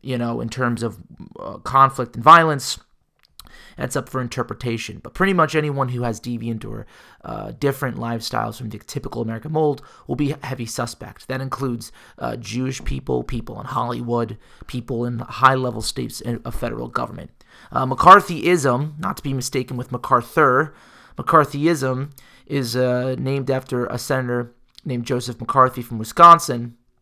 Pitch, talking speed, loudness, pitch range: 125 Hz, 155 wpm, -20 LUFS, 120-135 Hz